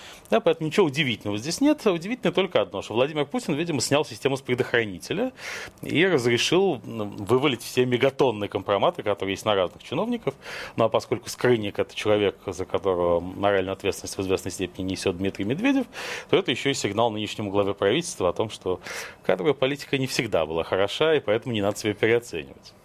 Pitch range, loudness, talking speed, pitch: 100-150 Hz, -25 LUFS, 175 wpm, 120 Hz